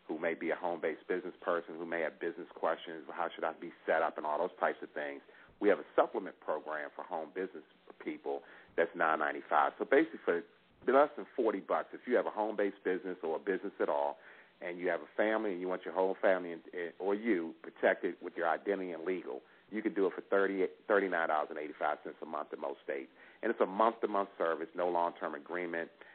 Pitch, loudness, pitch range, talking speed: 90 Hz, -35 LUFS, 80-95 Hz, 225 wpm